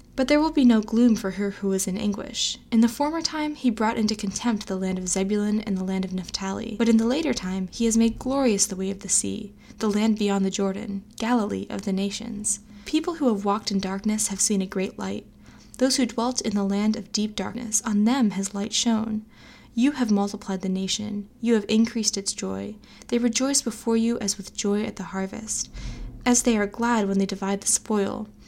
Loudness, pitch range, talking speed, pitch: -24 LUFS, 195-235 Hz, 225 wpm, 215 Hz